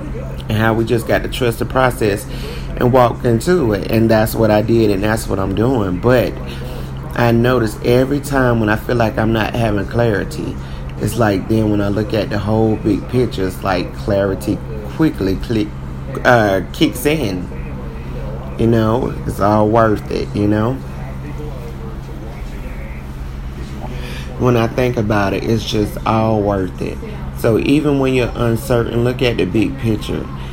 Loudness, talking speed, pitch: -16 LUFS, 165 wpm, 105 Hz